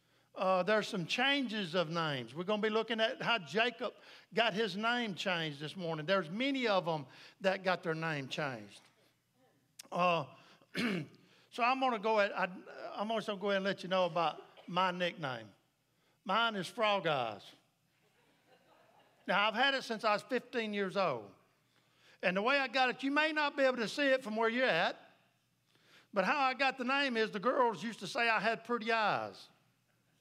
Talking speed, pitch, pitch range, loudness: 195 wpm, 210 Hz, 180-235 Hz, -34 LUFS